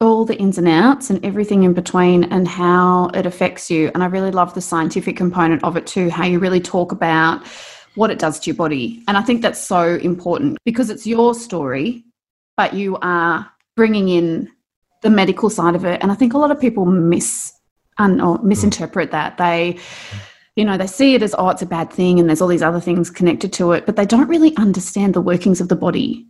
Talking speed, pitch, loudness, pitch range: 220 wpm, 185 Hz, -16 LUFS, 175-210 Hz